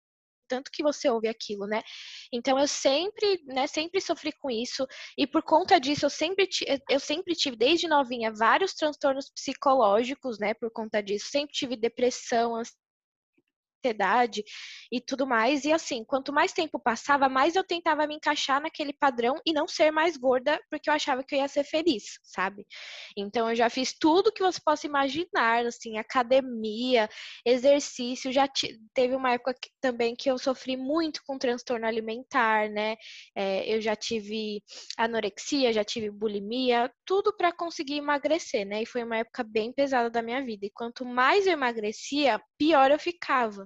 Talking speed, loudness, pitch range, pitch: 170 wpm, -27 LUFS, 230-300 Hz, 265 Hz